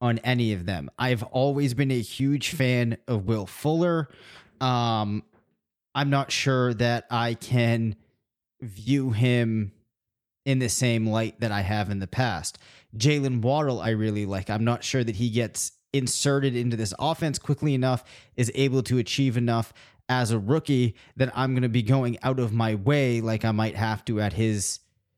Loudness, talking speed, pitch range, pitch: -25 LUFS, 175 wpm, 110-130 Hz, 120 Hz